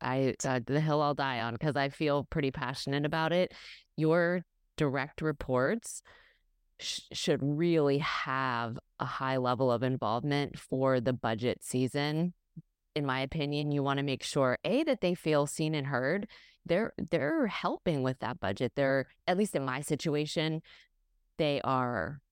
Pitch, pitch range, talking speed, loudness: 140 Hz, 130-155 Hz, 160 wpm, -32 LUFS